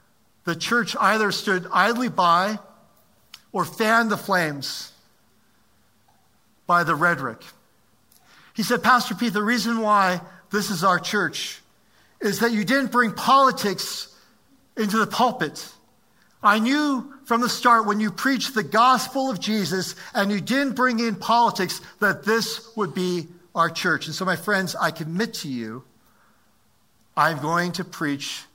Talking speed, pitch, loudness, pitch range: 145 wpm, 205 Hz, -22 LUFS, 175-230 Hz